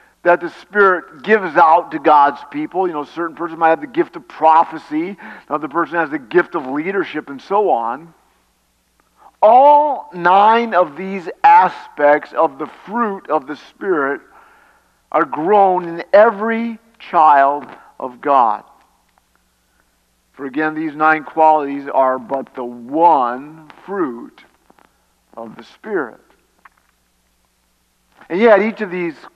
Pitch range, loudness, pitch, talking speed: 140-205 Hz, -15 LUFS, 165 Hz, 135 wpm